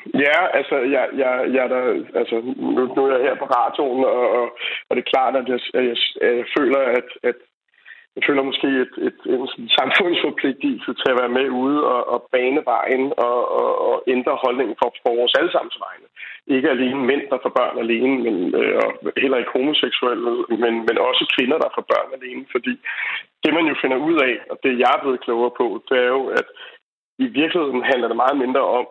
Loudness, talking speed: -19 LUFS, 170 wpm